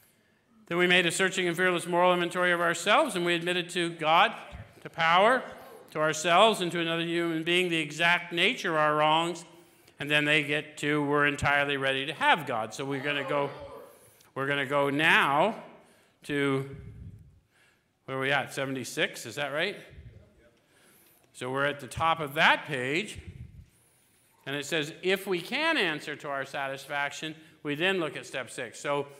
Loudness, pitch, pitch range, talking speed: -27 LUFS, 155 Hz, 140-175 Hz, 175 wpm